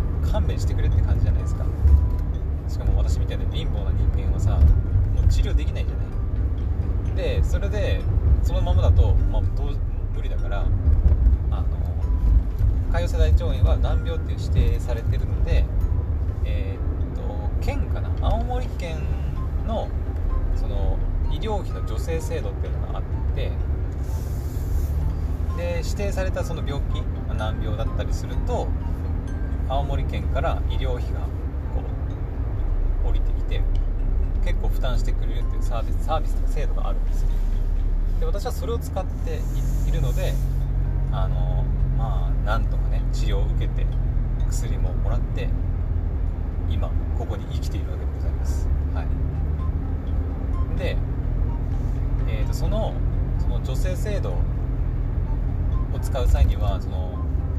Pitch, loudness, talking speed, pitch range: 85 Hz, -25 LUFS, 265 characters per minute, 80-90 Hz